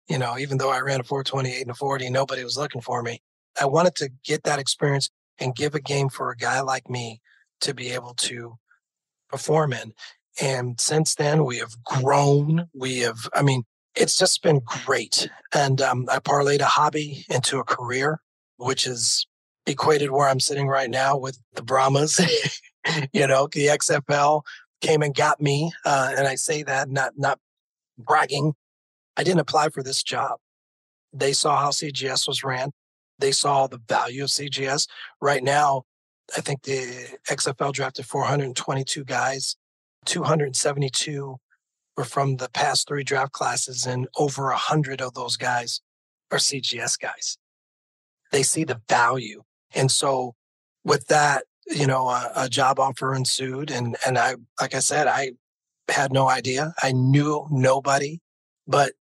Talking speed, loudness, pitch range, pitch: 165 wpm, -23 LUFS, 125-145 Hz, 135 Hz